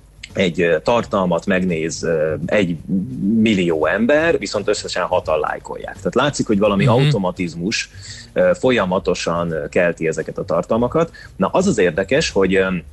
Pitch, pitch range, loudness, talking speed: 105 Hz, 90-135 Hz, -18 LUFS, 115 wpm